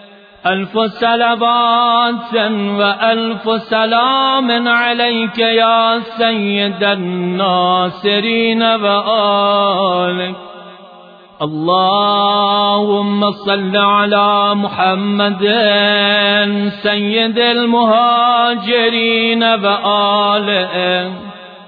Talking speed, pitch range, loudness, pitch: 45 wpm, 200-230 Hz, -13 LUFS, 205 Hz